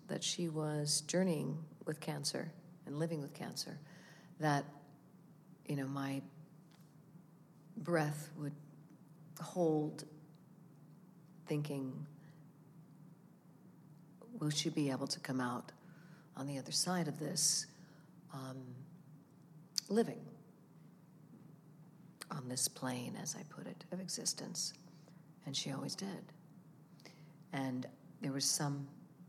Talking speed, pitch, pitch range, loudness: 100 wpm, 160 Hz, 150-170 Hz, -39 LUFS